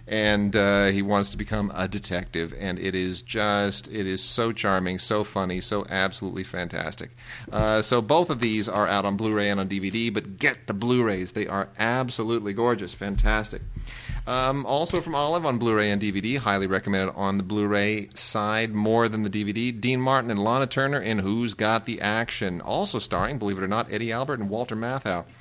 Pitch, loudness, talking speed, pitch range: 105 Hz, -25 LUFS, 190 wpm, 100-115 Hz